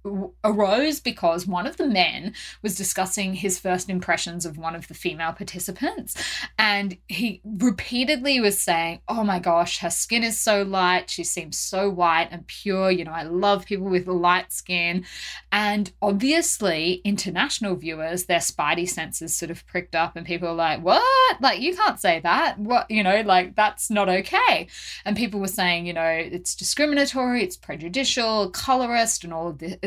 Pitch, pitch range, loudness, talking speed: 190 Hz, 175-220 Hz, -23 LUFS, 175 wpm